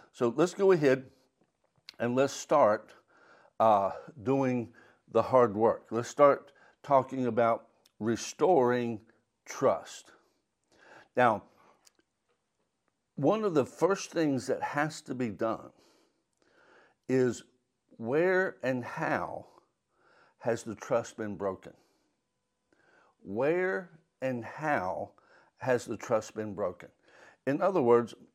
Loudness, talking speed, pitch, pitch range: -30 LUFS, 105 wpm, 125 Hz, 115-135 Hz